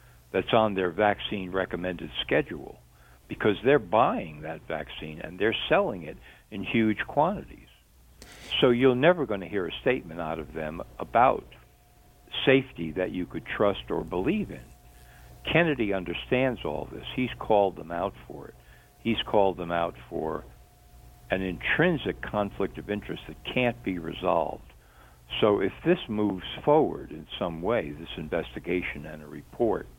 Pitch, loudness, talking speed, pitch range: 90 Hz, -27 LUFS, 150 wpm, 75-110 Hz